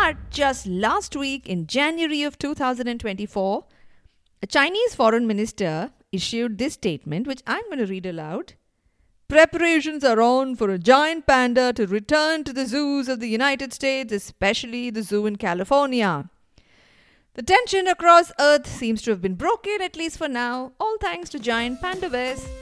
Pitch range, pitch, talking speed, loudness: 215-305 Hz, 260 Hz, 160 wpm, -22 LUFS